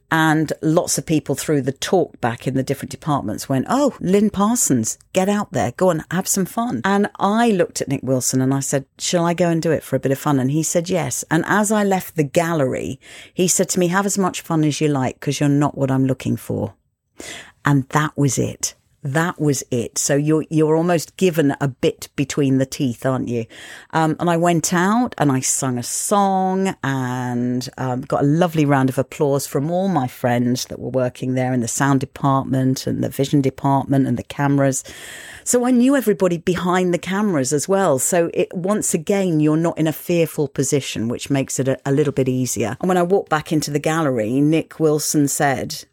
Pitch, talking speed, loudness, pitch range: 150 Hz, 215 wpm, -19 LUFS, 135-175 Hz